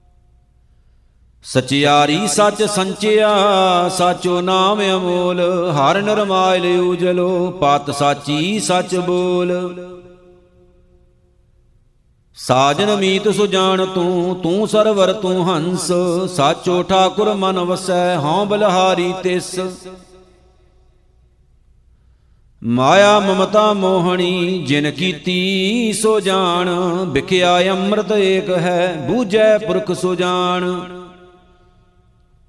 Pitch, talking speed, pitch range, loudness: 180 Hz, 80 wpm, 160-190 Hz, -15 LUFS